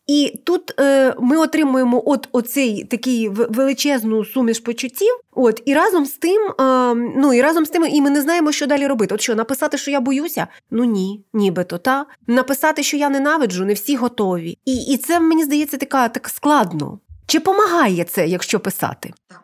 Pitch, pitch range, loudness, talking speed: 265 Hz, 230-295 Hz, -17 LUFS, 185 wpm